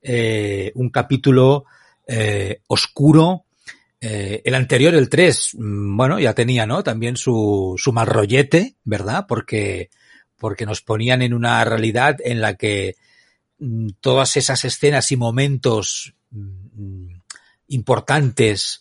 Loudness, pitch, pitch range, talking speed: -18 LUFS, 120 Hz, 110-135 Hz, 110 wpm